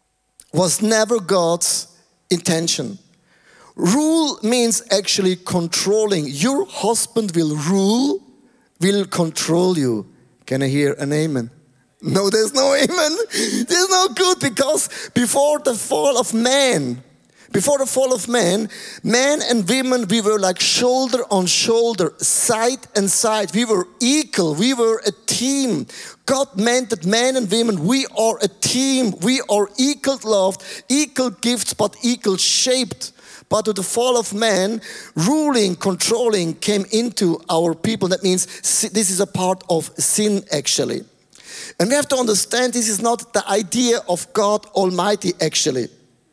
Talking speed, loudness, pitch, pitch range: 145 wpm, -18 LUFS, 220 Hz, 185-250 Hz